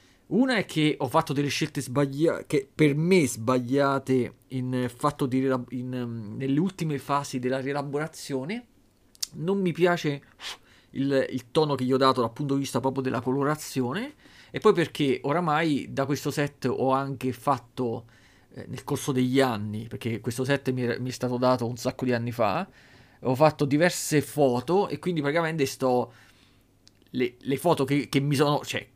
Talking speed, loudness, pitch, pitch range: 175 wpm, -26 LUFS, 135 Hz, 125-145 Hz